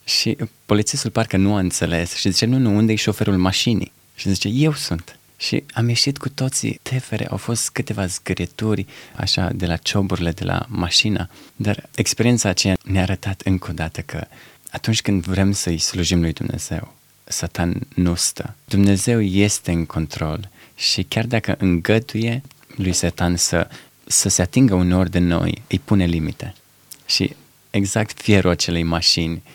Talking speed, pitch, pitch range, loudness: 160 wpm, 100 Hz, 90-115 Hz, -20 LUFS